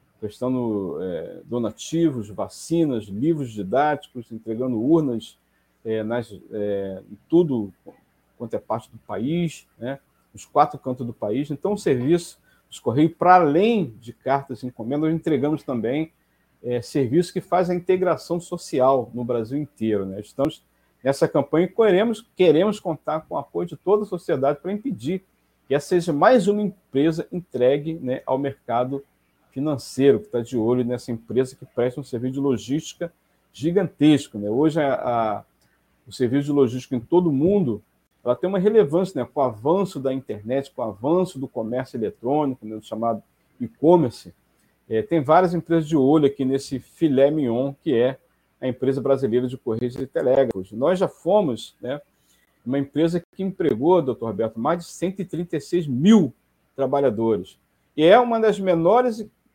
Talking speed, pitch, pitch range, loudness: 160 wpm, 140 Hz, 120-170 Hz, -22 LUFS